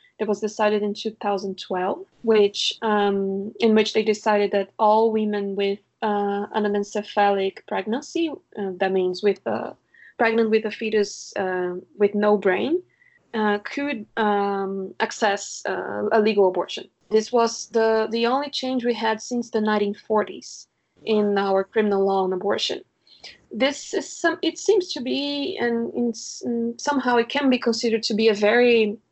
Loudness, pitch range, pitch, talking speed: -23 LUFS, 200-235 Hz, 215 Hz, 150 wpm